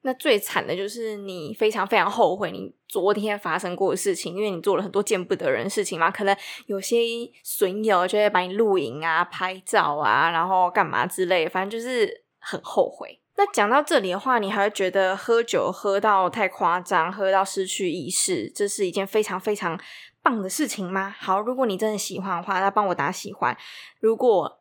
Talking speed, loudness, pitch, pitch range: 300 characters per minute, -23 LUFS, 200 Hz, 185-230 Hz